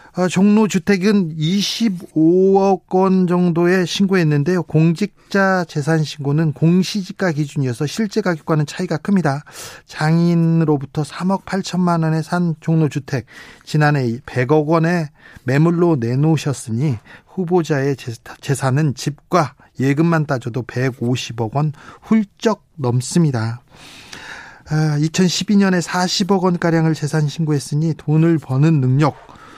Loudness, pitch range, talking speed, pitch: -17 LUFS, 145-180 Hz, 240 characters per minute, 160 Hz